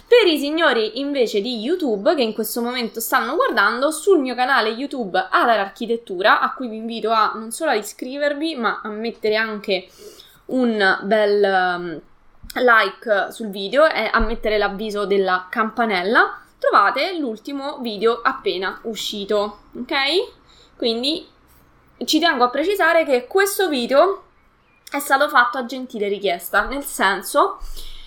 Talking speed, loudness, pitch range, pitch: 135 wpm, -19 LUFS, 215-290 Hz, 240 Hz